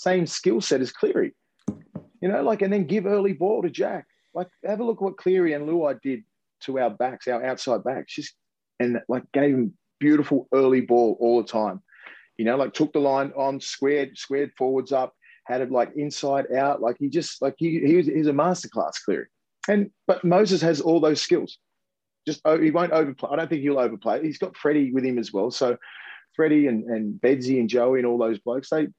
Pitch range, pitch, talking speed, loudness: 125-175 Hz, 140 Hz, 220 wpm, -23 LUFS